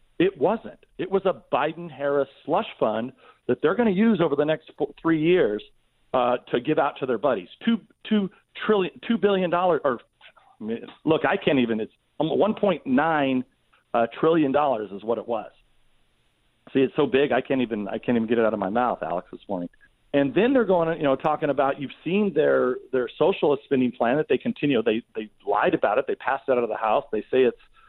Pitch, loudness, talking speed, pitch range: 150 Hz, -24 LUFS, 210 wpm, 125-205 Hz